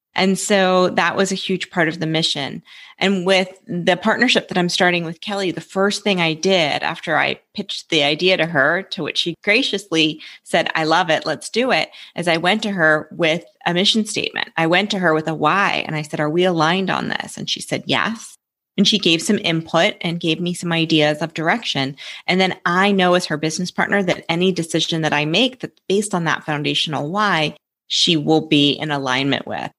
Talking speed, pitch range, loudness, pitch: 220 wpm, 160-190 Hz, -18 LUFS, 175 Hz